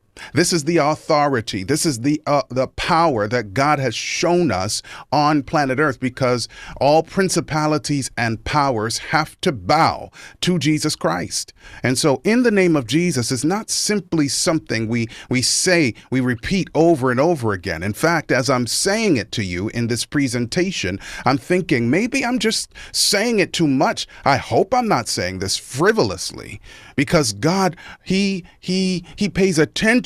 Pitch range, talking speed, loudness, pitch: 120-175 Hz, 165 wpm, -19 LUFS, 150 Hz